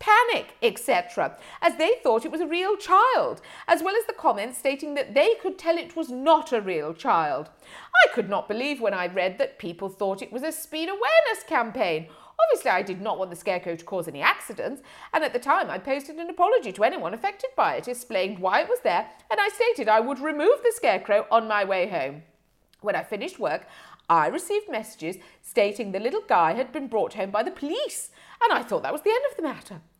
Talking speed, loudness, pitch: 220 wpm, -25 LUFS, 285 Hz